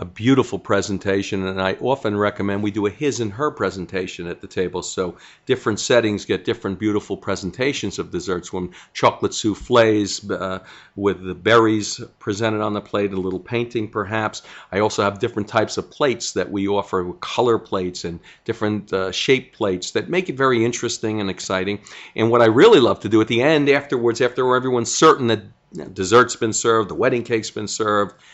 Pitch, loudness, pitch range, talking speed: 105 Hz, -20 LUFS, 95-120 Hz, 185 wpm